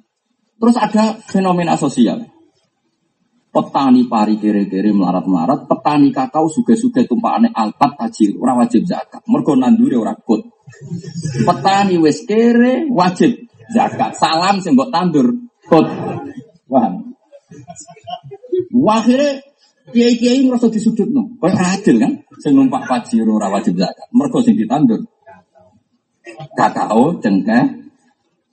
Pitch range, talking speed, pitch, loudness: 180-255 Hz, 105 wpm, 235 Hz, -14 LUFS